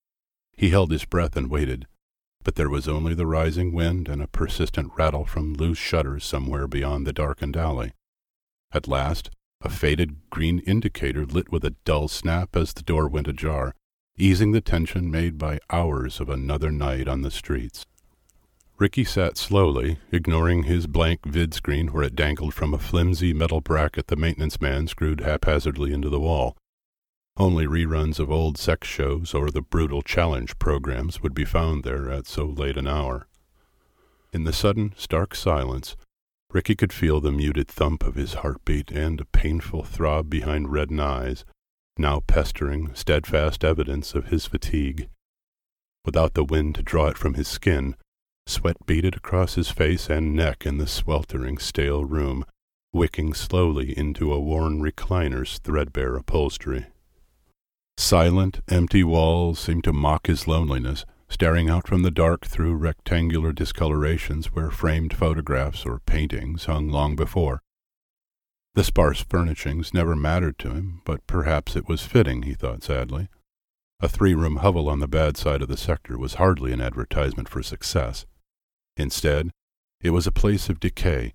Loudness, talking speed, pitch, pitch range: -24 LUFS, 160 wpm, 80 Hz, 75-85 Hz